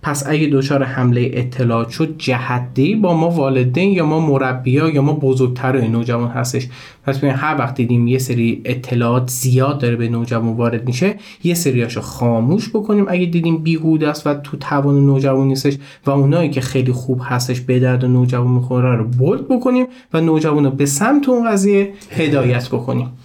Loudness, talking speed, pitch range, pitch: -16 LUFS, 170 wpm, 125-155 Hz, 135 Hz